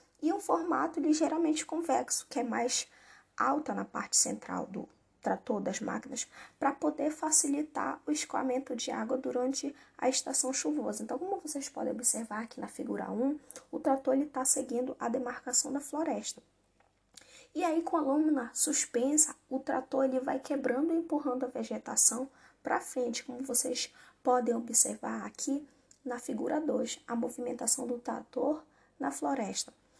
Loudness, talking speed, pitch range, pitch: -32 LUFS, 150 wpm, 255-300 Hz, 265 Hz